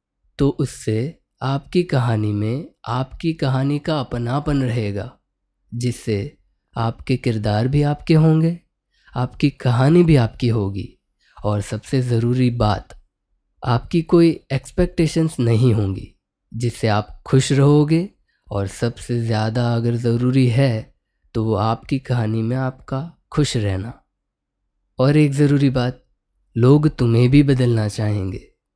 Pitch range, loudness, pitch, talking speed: 110-140 Hz, -19 LUFS, 125 Hz, 120 wpm